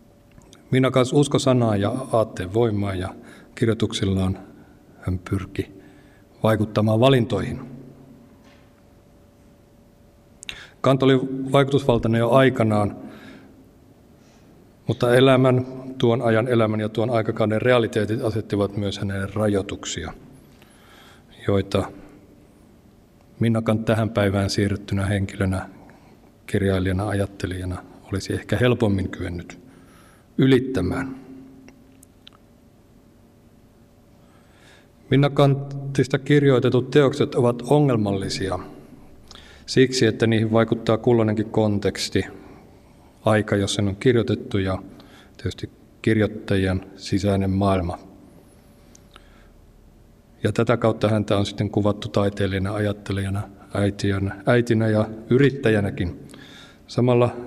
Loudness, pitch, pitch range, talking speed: -22 LUFS, 110 Hz, 100-120 Hz, 85 wpm